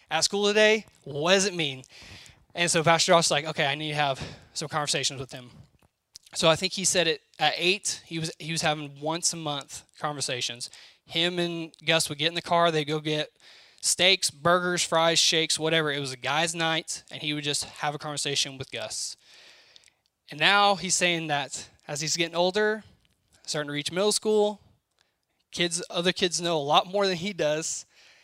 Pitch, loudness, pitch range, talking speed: 160 Hz, -25 LUFS, 150-175 Hz, 200 wpm